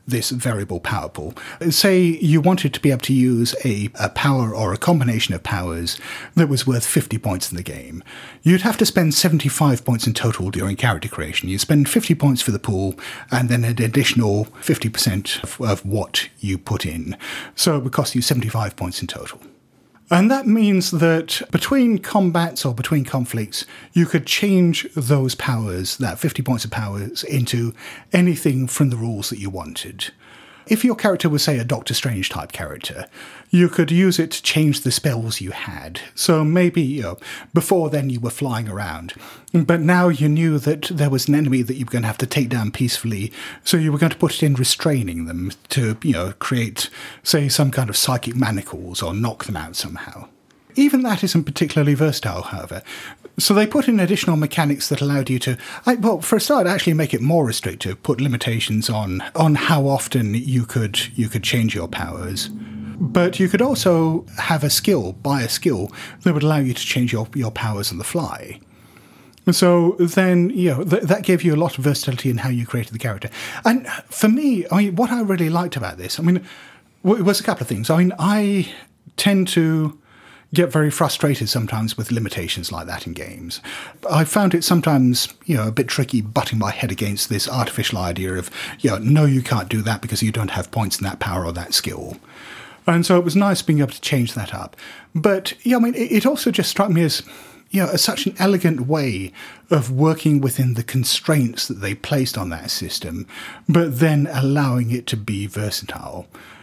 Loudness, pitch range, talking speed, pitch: -19 LUFS, 110-170 Hz, 205 wpm, 135 Hz